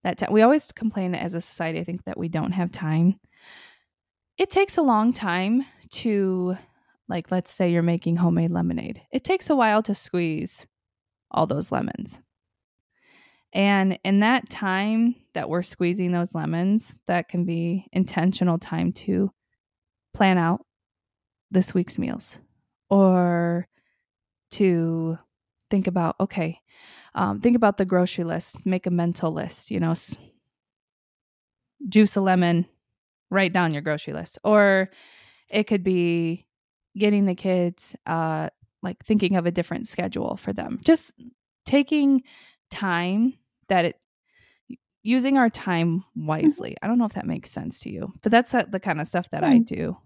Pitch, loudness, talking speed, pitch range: 185 Hz, -23 LUFS, 150 wpm, 170-220 Hz